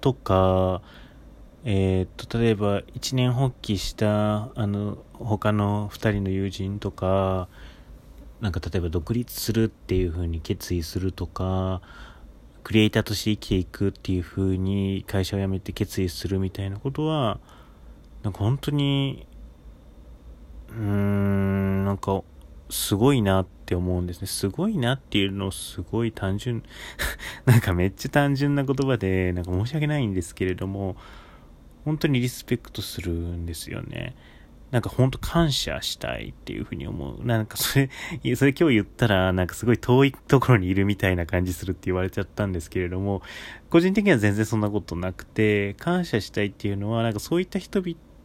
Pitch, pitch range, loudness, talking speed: 100 Hz, 90-115 Hz, -25 LUFS, 335 characters per minute